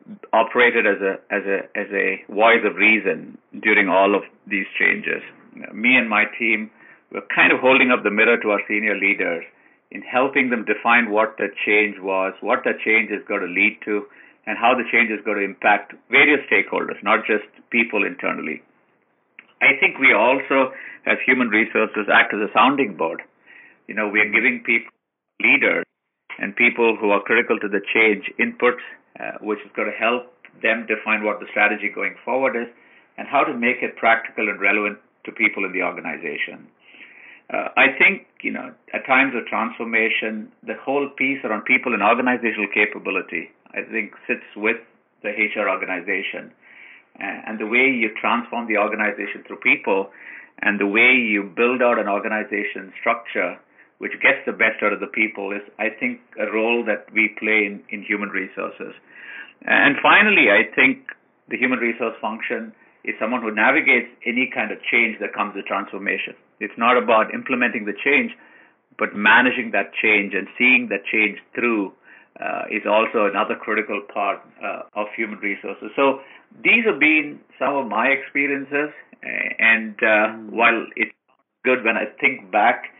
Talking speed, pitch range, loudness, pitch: 175 wpm, 105-125 Hz, -19 LUFS, 110 Hz